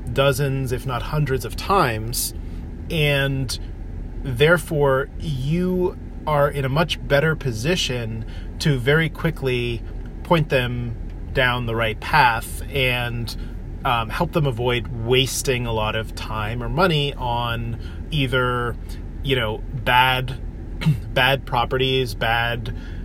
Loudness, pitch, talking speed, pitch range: -21 LUFS, 125 Hz, 115 wpm, 110-140 Hz